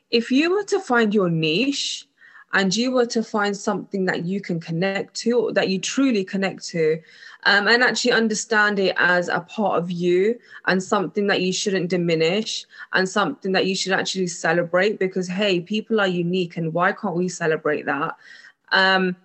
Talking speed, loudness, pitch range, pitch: 185 wpm, -21 LUFS, 180-215 Hz, 195 Hz